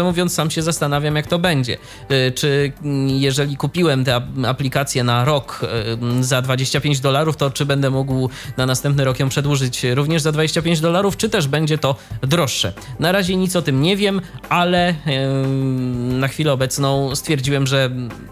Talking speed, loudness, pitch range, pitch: 155 wpm, -18 LUFS, 130-155 Hz, 140 Hz